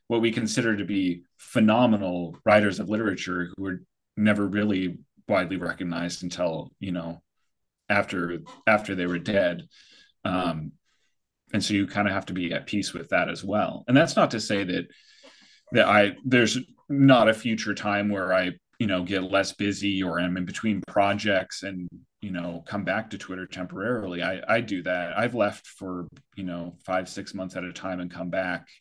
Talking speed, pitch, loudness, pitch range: 185 wpm, 95 Hz, -26 LUFS, 90-105 Hz